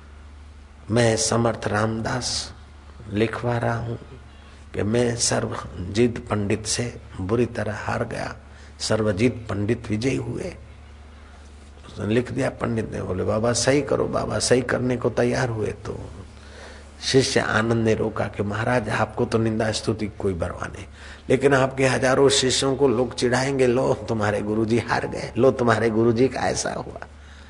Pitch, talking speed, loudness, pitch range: 110 Hz, 145 wpm, -23 LUFS, 90-120 Hz